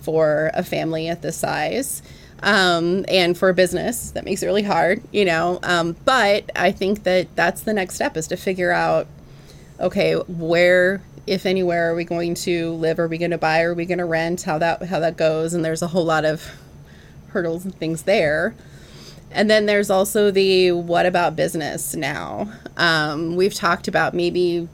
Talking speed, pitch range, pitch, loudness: 190 wpm, 165-190 Hz, 175 Hz, -20 LUFS